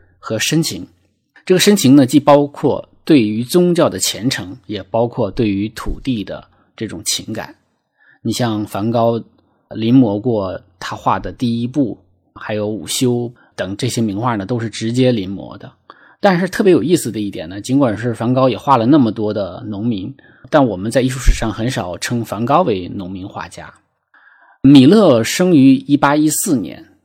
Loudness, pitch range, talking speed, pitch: -15 LUFS, 105-140 Hz, 250 characters per minute, 120 Hz